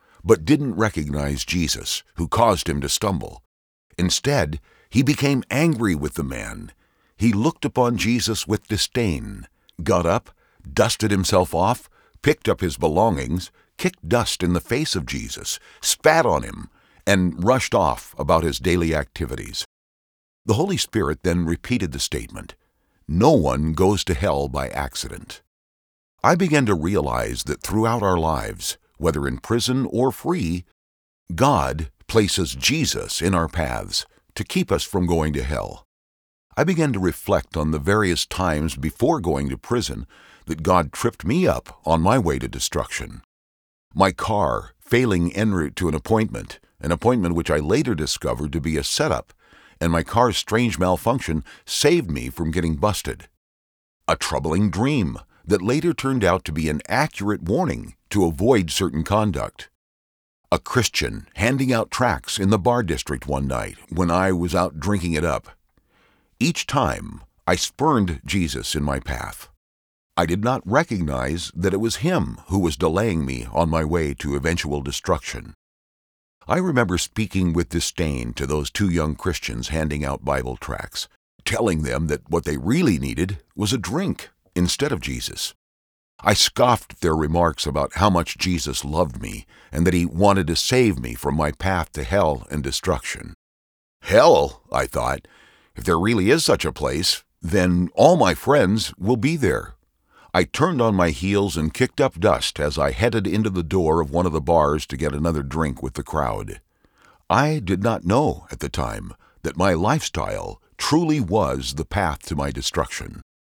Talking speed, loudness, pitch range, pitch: 165 wpm, -22 LUFS, 70-105 Hz, 85 Hz